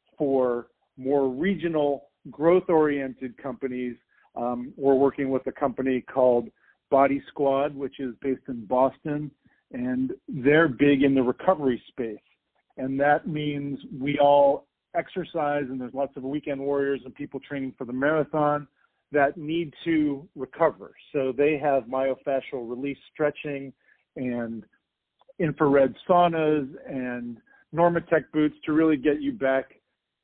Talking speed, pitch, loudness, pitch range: 130 wpm, 140 Hz, -25 LUFS, 130-150 Hz